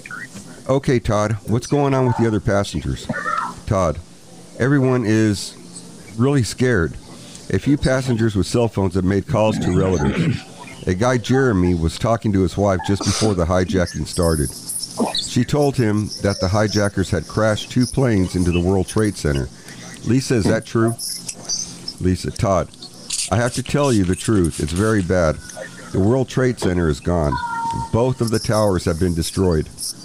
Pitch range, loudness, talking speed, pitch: 90-125 Hz, -19 LUFS, 165 wpm, 105 Hz